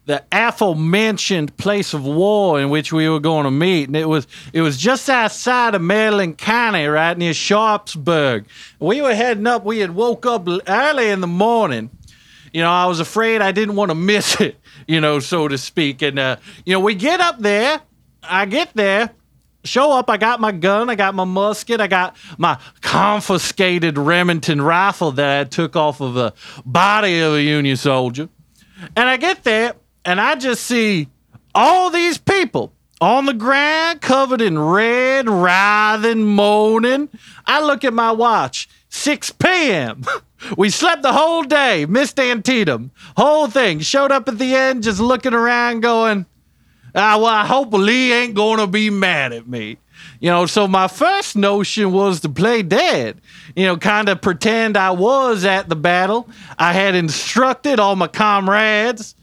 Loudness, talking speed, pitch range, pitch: -16 LUFS, 175 wpm, 170-235 Hz, 205 Hz